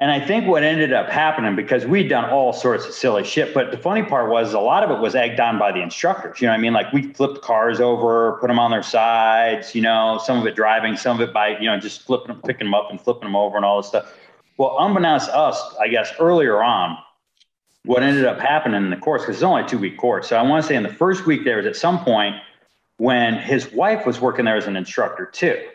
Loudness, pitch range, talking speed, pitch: -19 LUFS, 110-140 Hz, 275 wpm, 120 Hz